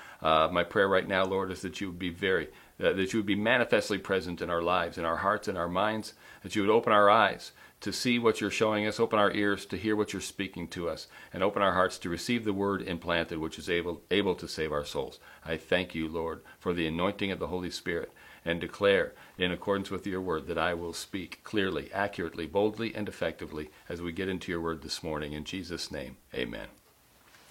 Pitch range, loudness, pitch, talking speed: 85-100 Hz, -30 LUFS, 90 Hz, 230 wpm